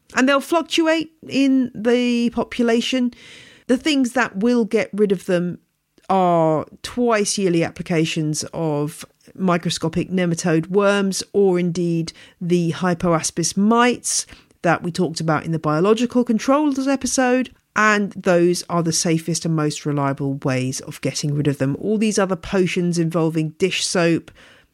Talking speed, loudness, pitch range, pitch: 140 wpm, -20 LUFS, 165-235 Hz, 180 Hz